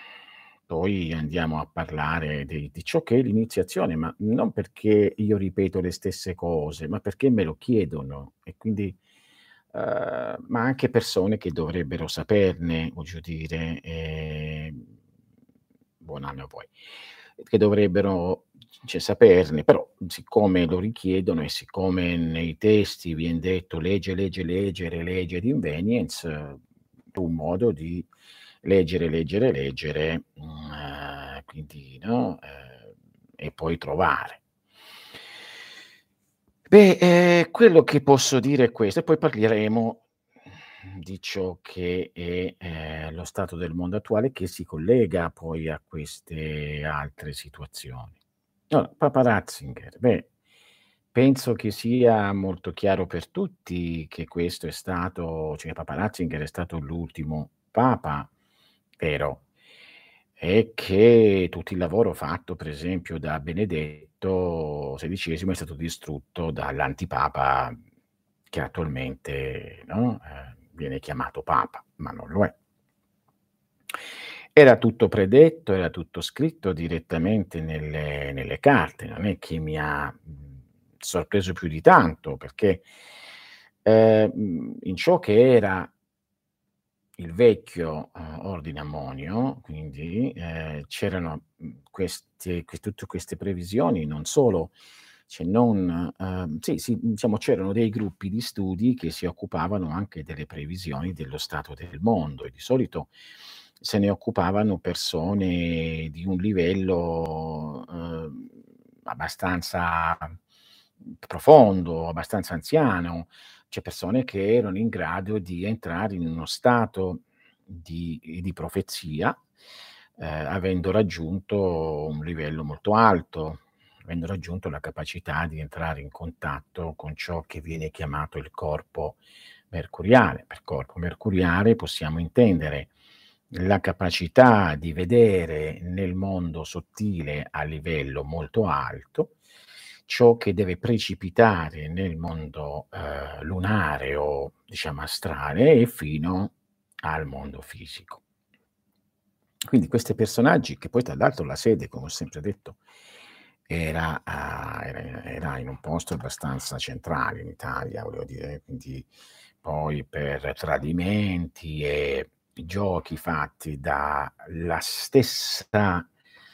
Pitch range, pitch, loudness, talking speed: 80-100 Hz, 85 Hz, -24 LUFS, 120 wpm